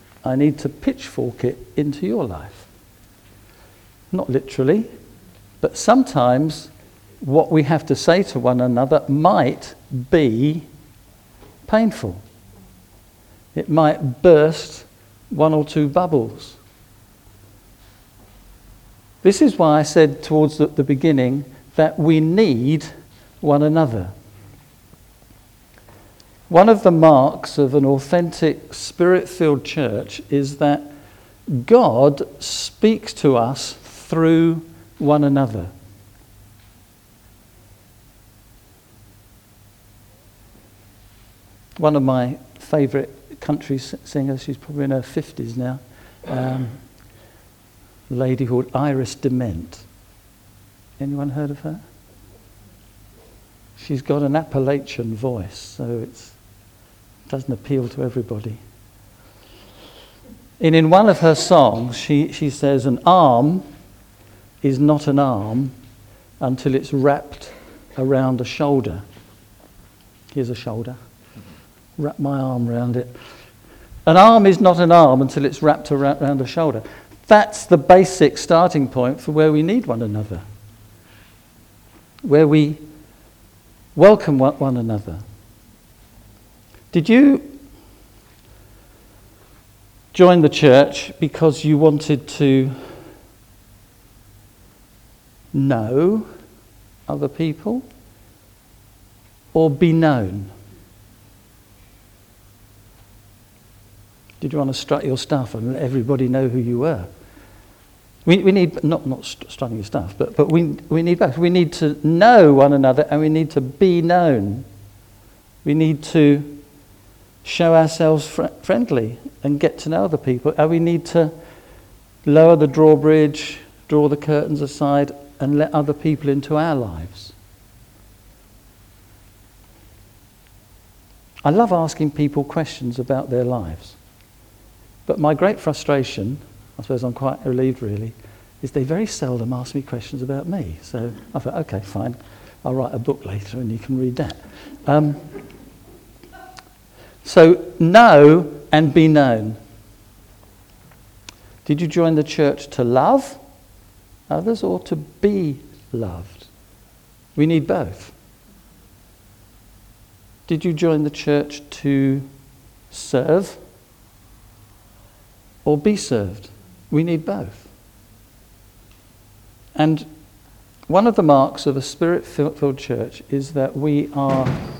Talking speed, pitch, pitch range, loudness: 115 wpm, 125 Hz, 105-150 Hz, -17 LUFS